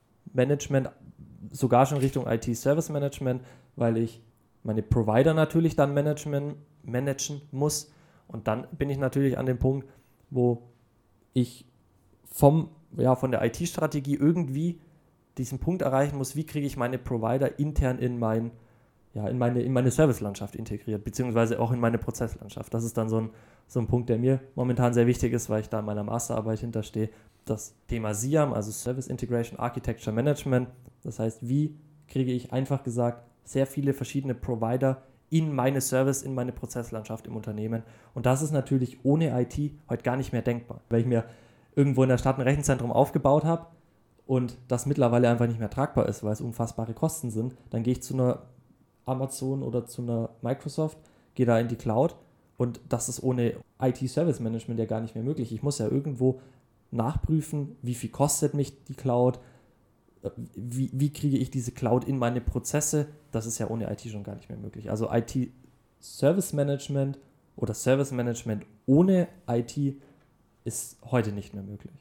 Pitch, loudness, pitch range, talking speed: 125 Hz, -28 LUFS, 115-140 Hz, 170 wpm